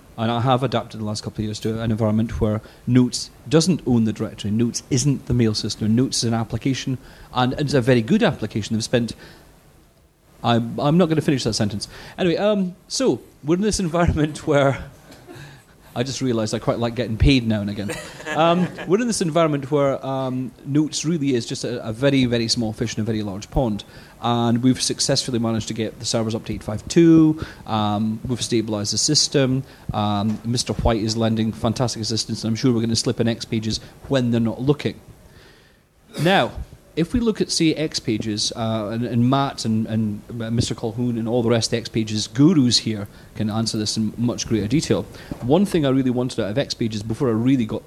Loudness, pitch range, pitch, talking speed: -21 LUFS, 110-135 Hz, 120 Hz, 205 wpm